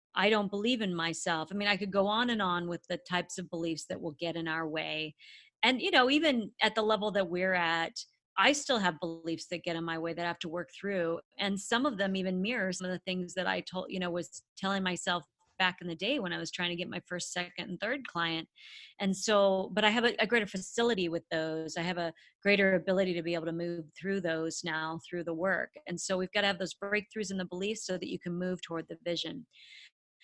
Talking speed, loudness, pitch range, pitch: 255 wpm, -32 LUFS, 170-200 Hz, 180 Hz